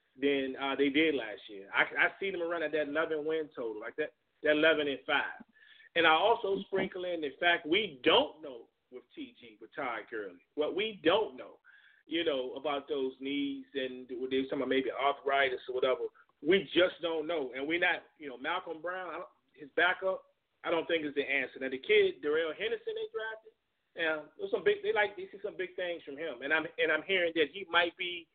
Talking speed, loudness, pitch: 220 wpm, -32 LUFS, 175 Hz